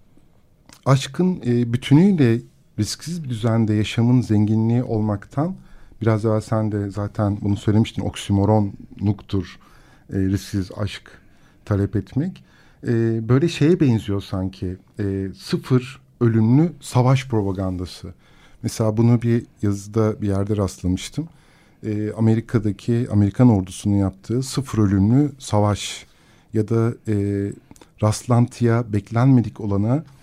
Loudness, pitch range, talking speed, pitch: -21 LUFS, 100-125 Hz, 95 wpm, 110 Hz